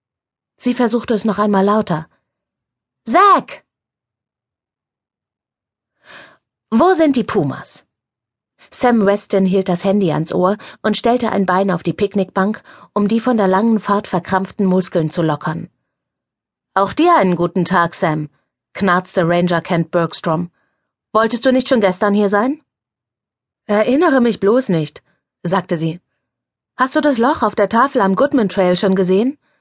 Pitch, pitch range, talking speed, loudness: 195 Hz, 175-230 Hz, 140 wpm, -16 LUFS